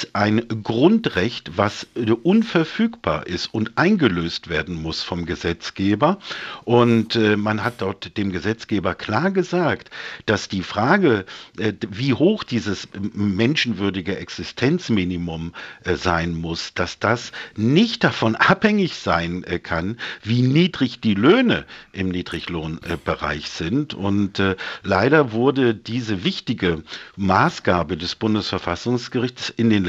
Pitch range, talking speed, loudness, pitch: 90-125 Hz, 105 wpm, -21 LUFS, 105 Hz